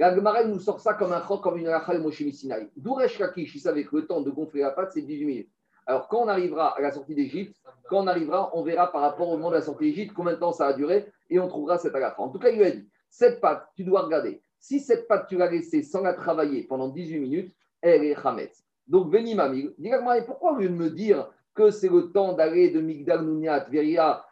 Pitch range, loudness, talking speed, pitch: 155-210 Hz, -25 LUFS, 250 wpm, 180 Hz